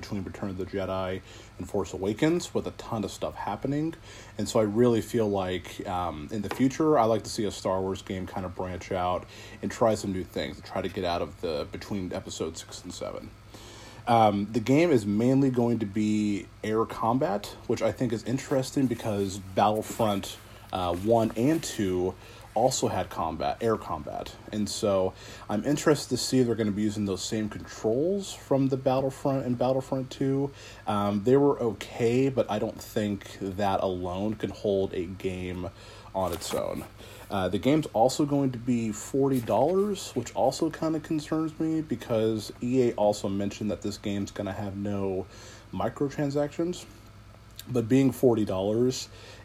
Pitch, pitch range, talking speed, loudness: 110 Hz, 100-125 Hz, 180 wpm, -28 LUFS